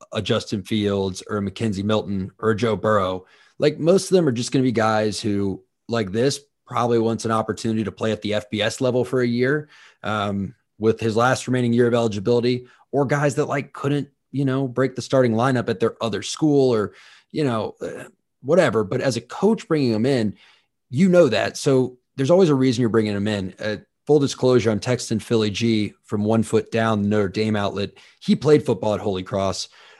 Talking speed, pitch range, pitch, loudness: 210 wpm, 105-130 Hz, 115 Hz, -21 LUFS